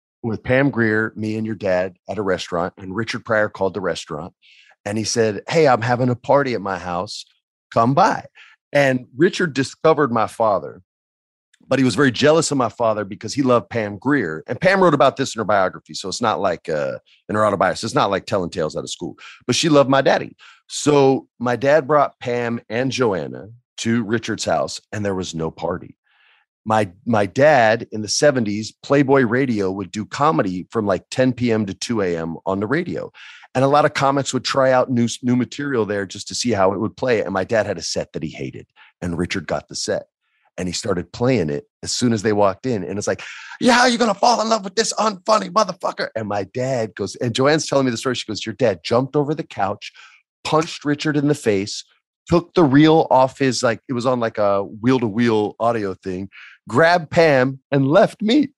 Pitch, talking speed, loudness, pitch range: 120 Hz, 220 wpm, -19 LUFS, 105-140 Hz